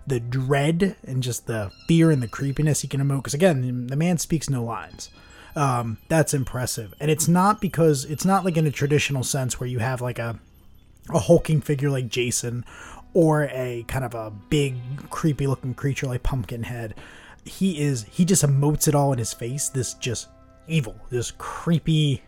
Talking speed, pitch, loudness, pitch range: 185 wpm, 140 Hz, -23 LUFS, 120-155 Hz